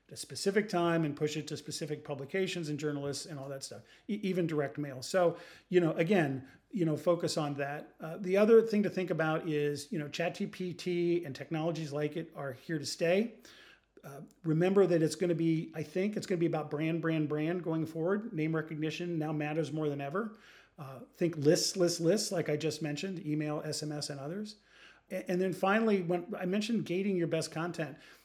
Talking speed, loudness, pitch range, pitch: 200 wpm, -33 LUFS, 150-185 Hz, 165 Hz